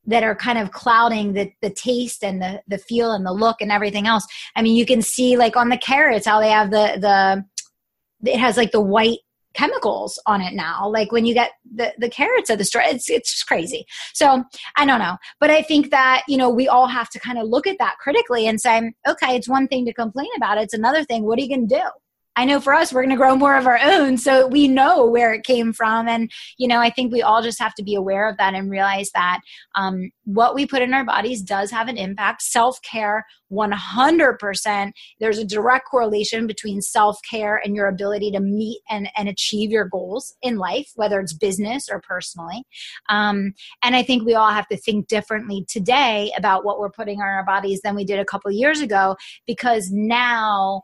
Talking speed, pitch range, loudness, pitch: 225 wpm, 205-250 Hz, -19 LUFS, 225 Hz